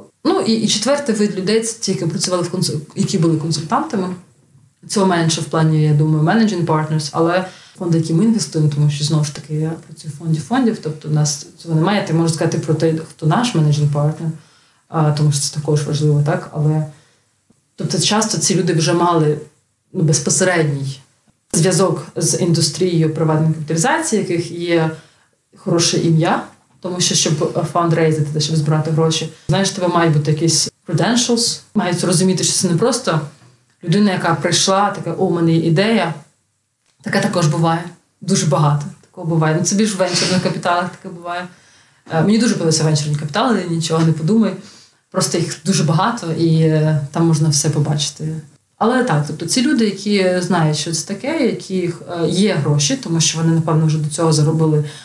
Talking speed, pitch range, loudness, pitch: 165 wpm, 155-185 Hz, -16 LUFS, 165 Hz